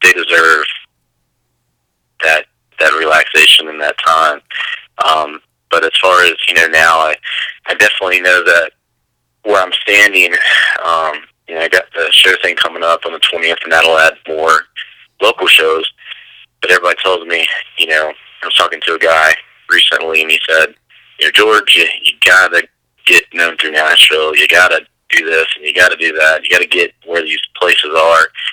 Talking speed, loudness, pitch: 180 wpm, -9 LUFS, 80 Hz